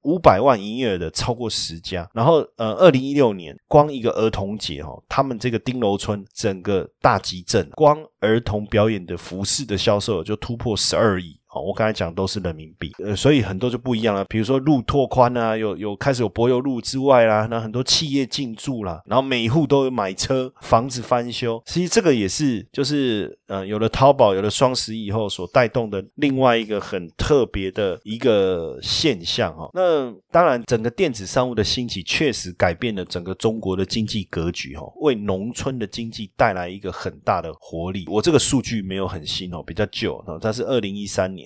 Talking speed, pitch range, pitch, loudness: 310 characters per minute, 95-130 Hz, 110 Hz, -21 LUFS